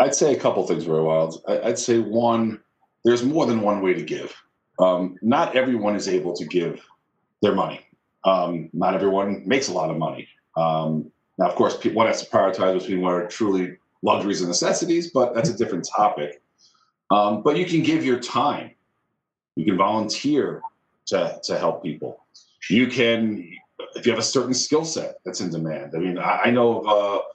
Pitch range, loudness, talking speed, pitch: 90-125 Hz, -22 LUFS, 190 wpm, 105 Hz